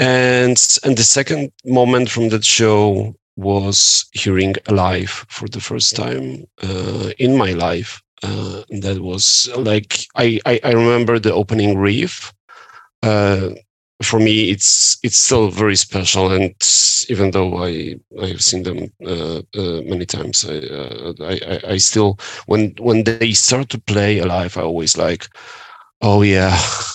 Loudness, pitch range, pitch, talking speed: -15 LUFS, 95-115 Hz, 105 Hz, 150 wpm